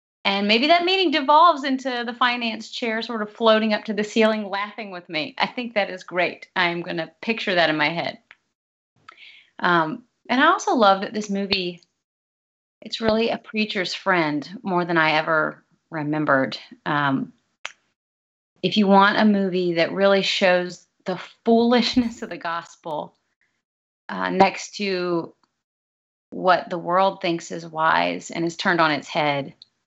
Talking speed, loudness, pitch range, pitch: 160 wpm, -21 LUFS, 170-225 Hz, 195 Hz